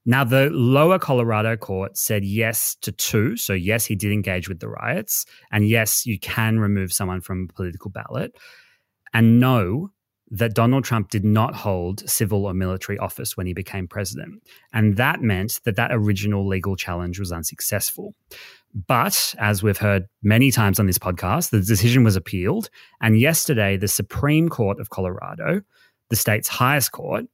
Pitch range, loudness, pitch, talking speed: 95-120 Hz, -21 LUFS, 105 Hz, 170 wpm